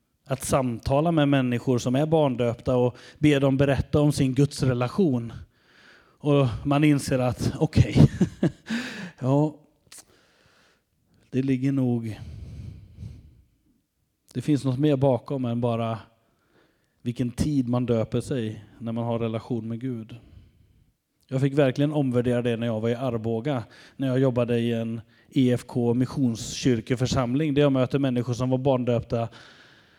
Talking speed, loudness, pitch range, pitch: 135 wpm, -25 LUFS, 115-140 Hz, 125 Hz